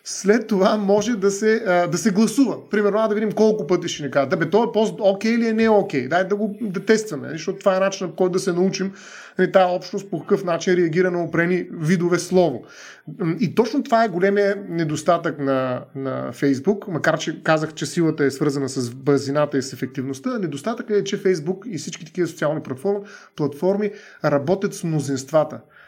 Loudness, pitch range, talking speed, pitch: -21 LUFS, 155-205 Hz, 195 wpm, 180 Hz